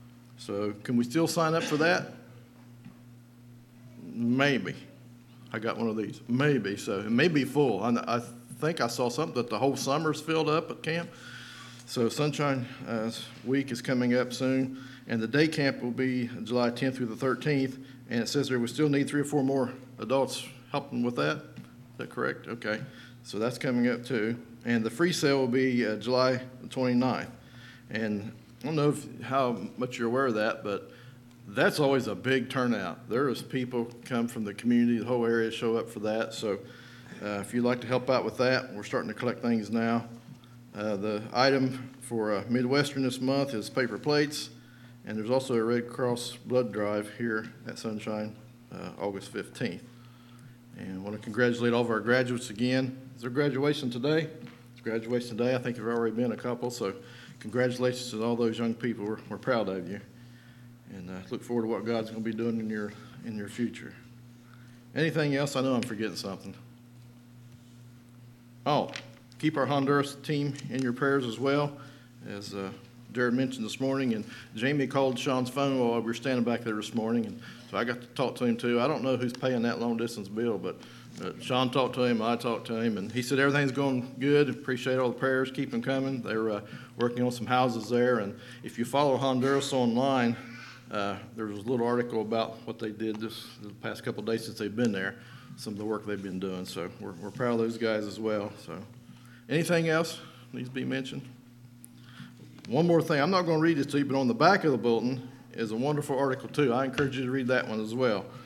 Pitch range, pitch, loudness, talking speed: 115-130 Hz, 120 Hz, -30 LUFS, 205 wpm